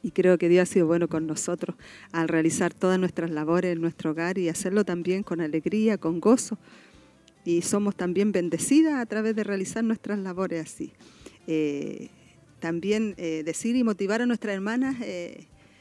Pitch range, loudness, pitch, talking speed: 170-215 Hz, -26 LUFS, 185 Hz, 170 wpm